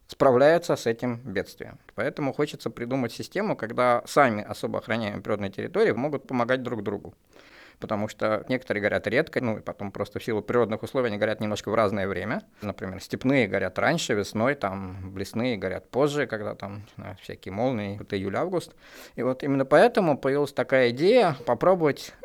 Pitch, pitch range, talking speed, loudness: 115 Hz, 105-130 Hz, 160 wpm, -26 LUFS